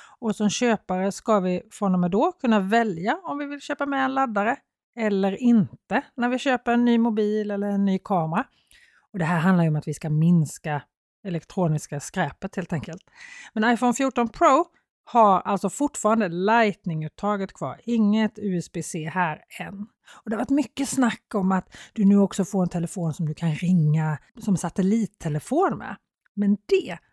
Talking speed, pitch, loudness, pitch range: 175 wpm, 205 Hz, -24 LUFS, 180-235 Hz